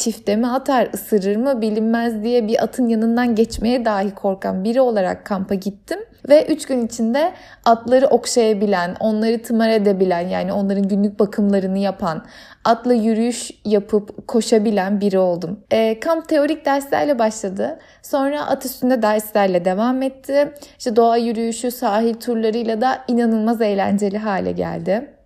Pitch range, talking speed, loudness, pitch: 205-255 Hz, 140 wpm, -18 LUFS, 225 Hz